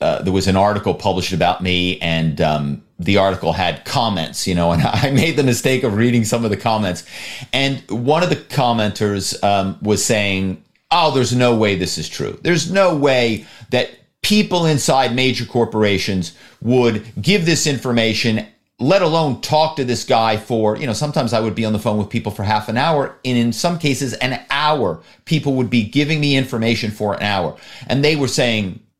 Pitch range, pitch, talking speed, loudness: 105-135 Hz, 115 Hz, 195 wpm, -17 LUFS